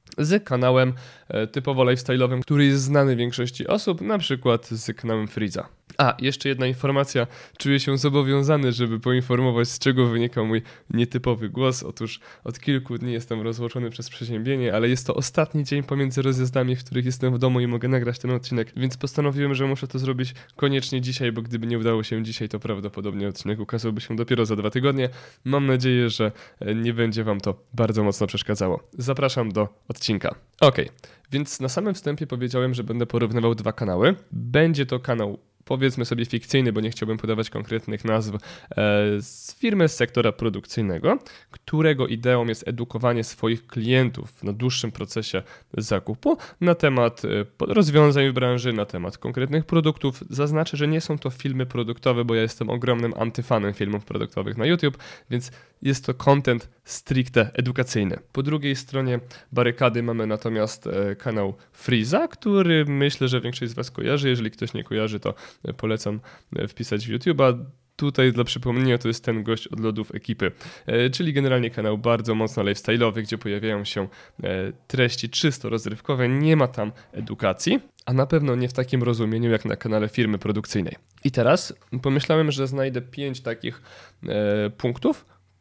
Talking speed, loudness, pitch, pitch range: 160 wpm, -24 LUFS, 120 Hz, 110-135 Hz